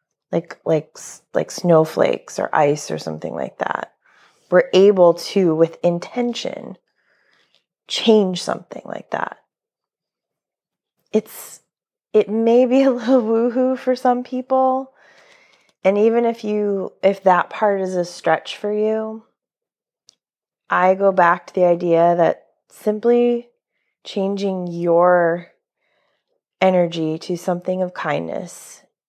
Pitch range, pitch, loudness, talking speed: 175-235 Hz, 195 Hz, -18 LUFS, 115 wpm